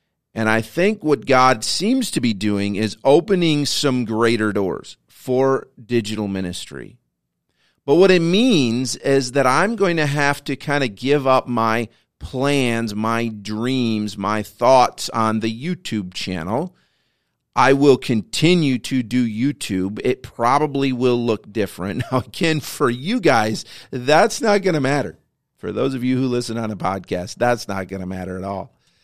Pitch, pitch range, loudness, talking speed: 125 Hz, 110-140 Hz, -19 LUFS, 165 wpm